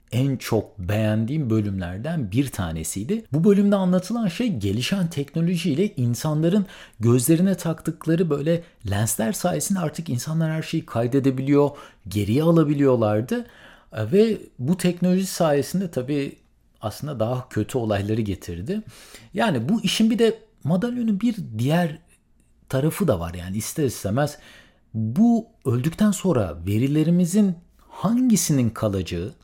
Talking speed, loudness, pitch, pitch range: 110 wpm, -23 LUFS, 150 Hz, 110-180 Hz